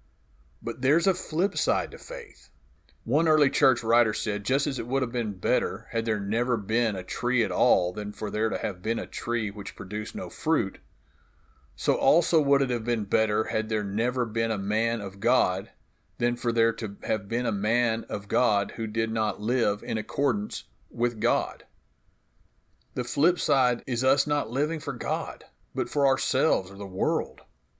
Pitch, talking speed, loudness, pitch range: 115 Hz, 190 wpm, -27 LUFS, 105-130 Hz